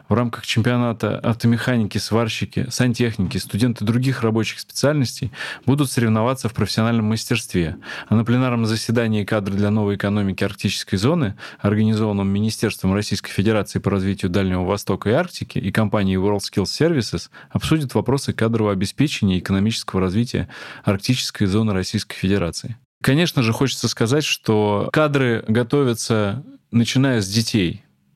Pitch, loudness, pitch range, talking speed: 110 Hz, -20 LUFS, 100-120 Hz, 130 wpm